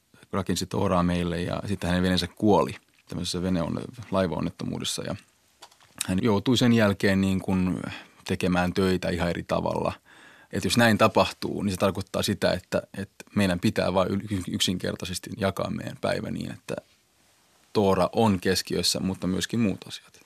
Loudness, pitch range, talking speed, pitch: -26 LUFS, 90-100 Hz, 145 wpm, 95 Hz